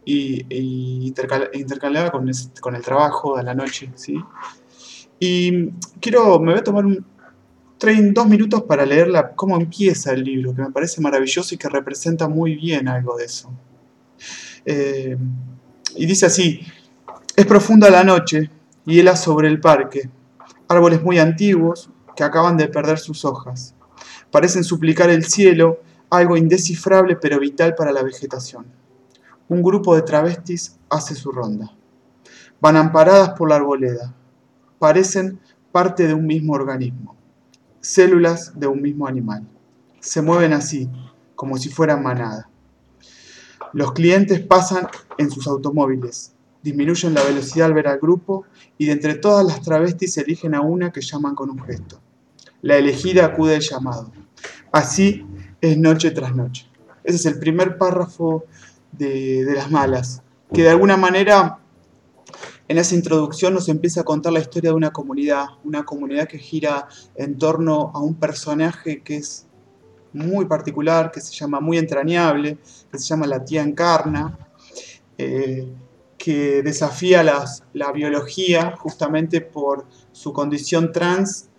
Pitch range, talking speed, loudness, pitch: 135-170 Hz, 150 wpm, -17 LUFS, 155 Hz